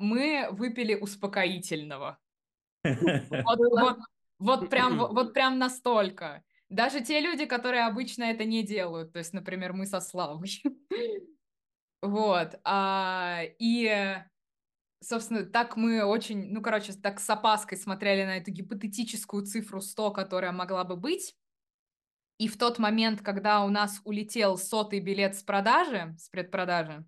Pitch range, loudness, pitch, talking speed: 190-235 Hz, -29 LUFS, 210 Hz, 135 wpm